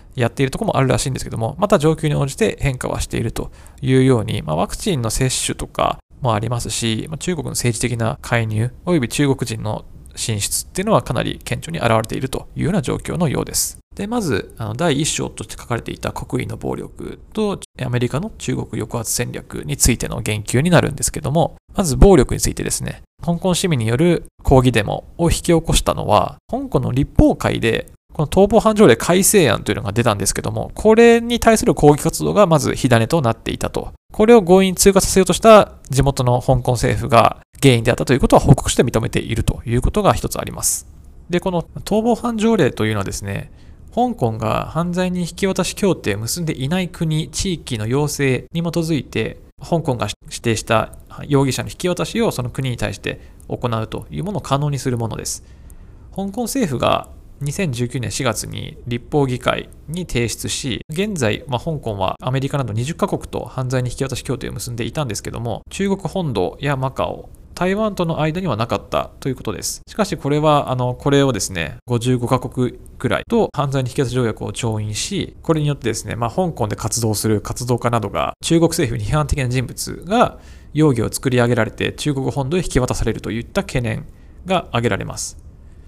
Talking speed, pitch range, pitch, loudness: 395 characters per minute, 115-165 Hz, 130 Hz, -18 LUFS